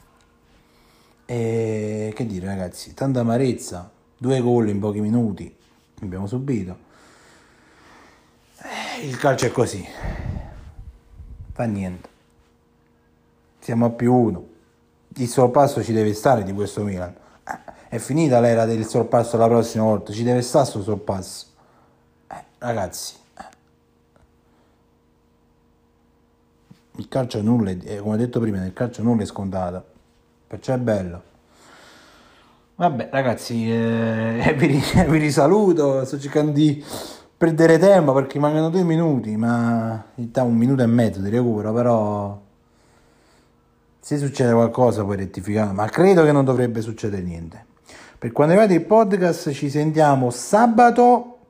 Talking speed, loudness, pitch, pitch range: 135 wpm, -20 LUFS, 115 Hz, 95-130 Hz